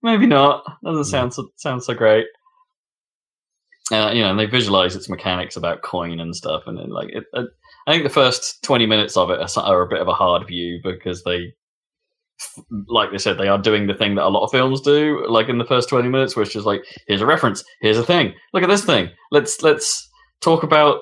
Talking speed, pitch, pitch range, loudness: 225 wpm, 125 Hz, 100-165 Hz, -18 LUFS